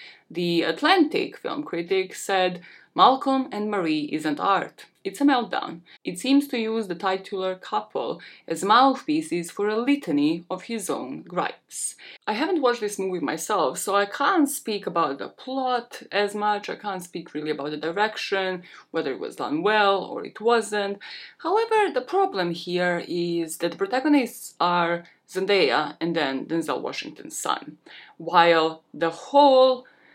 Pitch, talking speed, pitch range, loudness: 205 Hz, 155 wpm, 175-270 Hz, -24 LUFS